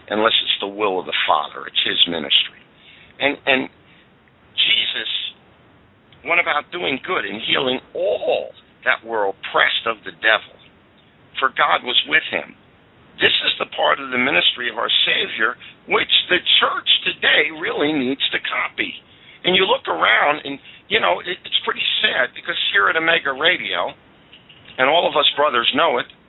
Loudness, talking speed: -18 LUFS, 160 wpm